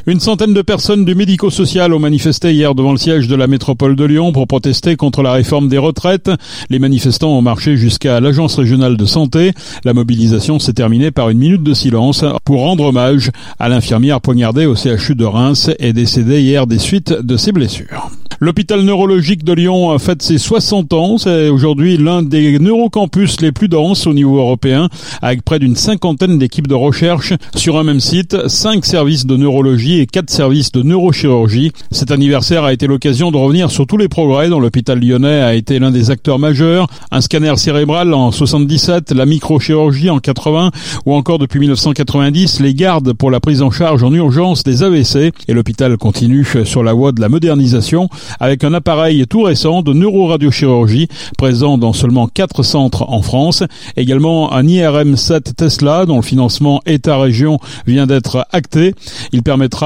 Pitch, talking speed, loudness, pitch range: 145 Hz, 180 wpm, -11 LUFS, 130-165 Hz